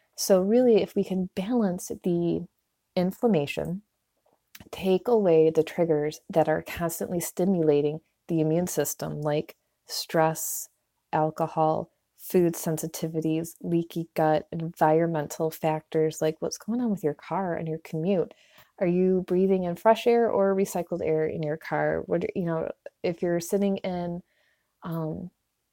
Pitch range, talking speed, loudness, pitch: 155-190 Hz, 135 wpm, -26 LUFS, 170 Hz